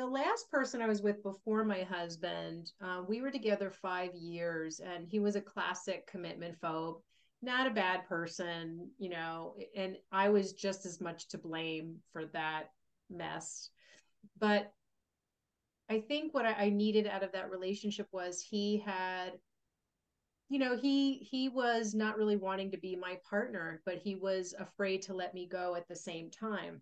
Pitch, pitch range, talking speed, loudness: 190 Hz, 175-210 Hz, 170 wpm, -37 LUFS